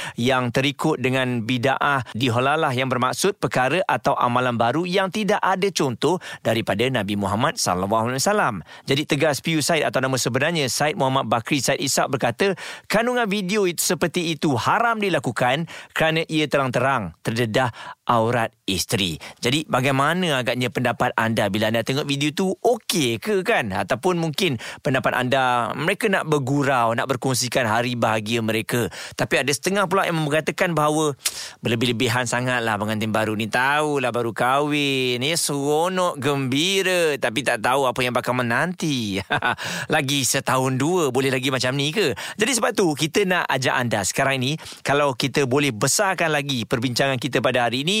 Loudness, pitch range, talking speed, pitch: -21 LUFS, 125-160 Hz, 155 wpm, 140 Hz